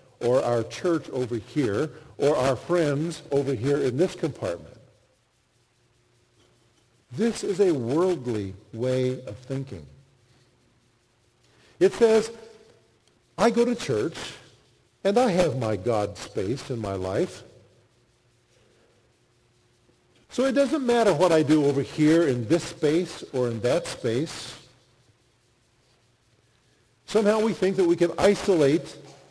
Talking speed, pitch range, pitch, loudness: 120 wpm, 120-180 Hz, 130 Hz, -25 LUFS